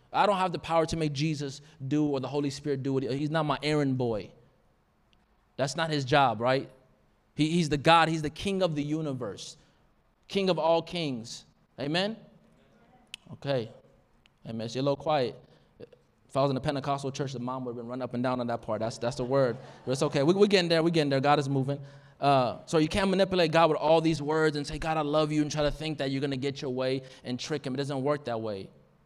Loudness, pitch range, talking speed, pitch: -28 LUFS, 130-155 Hz, 245 wpm, 145 Hz